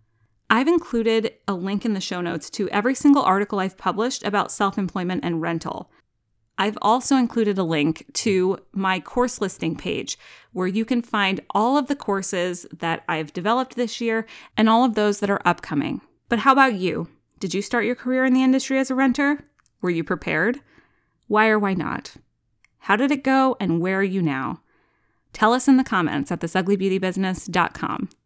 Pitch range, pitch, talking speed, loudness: 185-245 Hz, 200 Hz, 185 wpm, -22 LUFS